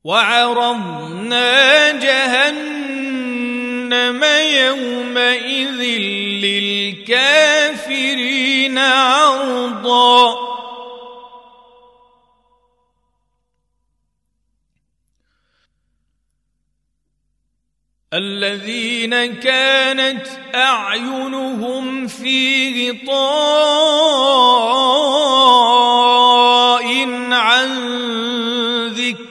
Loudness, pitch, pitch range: -14 LUFS, 245 Hz, 240-265 Hz